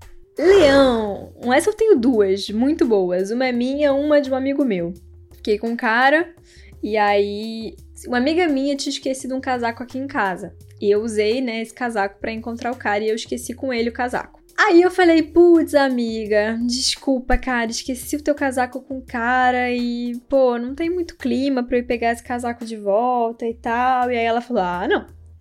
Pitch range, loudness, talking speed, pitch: 225-275 Hz, -19 LUFS, 200 wpm, 245 Hz